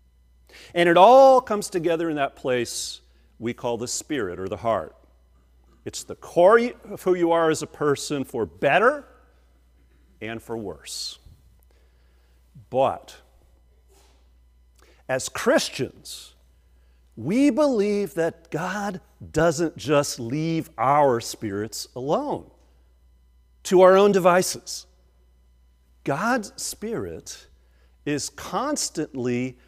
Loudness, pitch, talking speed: -22 LUFS, 110 Hz, 105 wpm